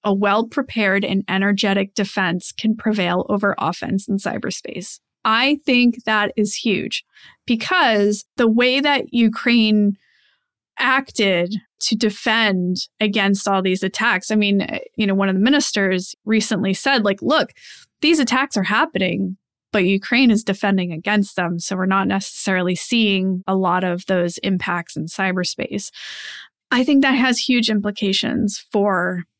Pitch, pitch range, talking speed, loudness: 205 Hz, 190-225 Hz, 145 wpm, -18 LUFS